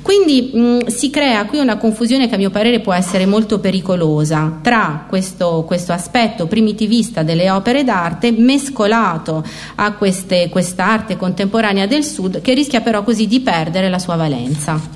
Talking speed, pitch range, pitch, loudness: 155 wpm, 180-235 Hz, 205 Hz, -15 LUFS